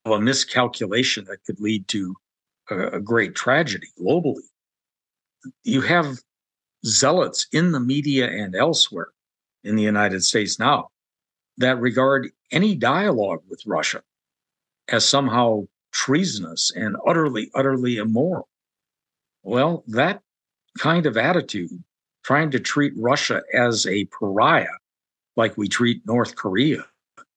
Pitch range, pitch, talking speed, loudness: 105-135 Hz, 120 Hz, 115 wpm, -21 LUFS